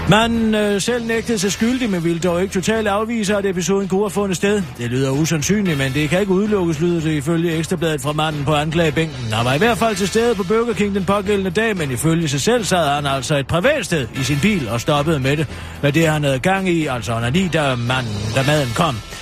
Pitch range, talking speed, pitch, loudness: 145-205 Hz, 245 wpm, 170 Hz, -18 LUFS